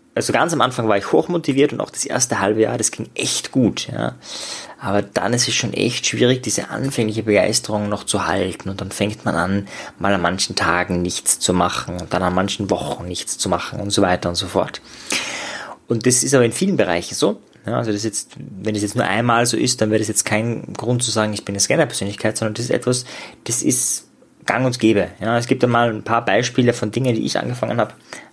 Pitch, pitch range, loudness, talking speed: 110 Hz, 100-120 Hz, -19 LUFS, 235 wpm